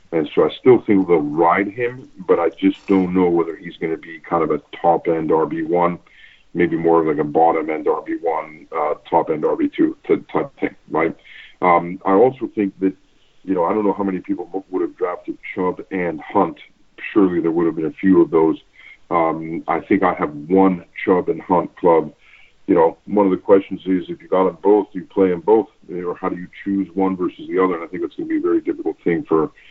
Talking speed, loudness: 235 wpm, -19 LUFS